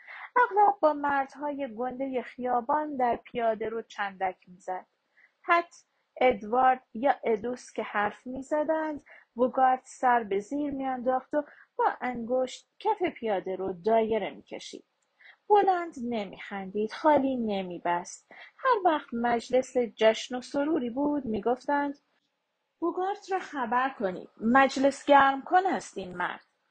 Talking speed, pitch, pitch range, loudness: 115 wpm, 255 Hz, 225-290 Hz, -28 LUFS